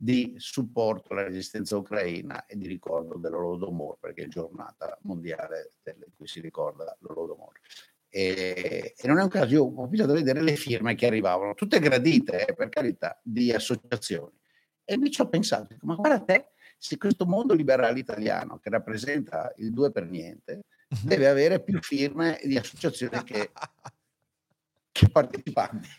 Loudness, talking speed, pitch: -27 LUFS, 155 wpm, 145 Hz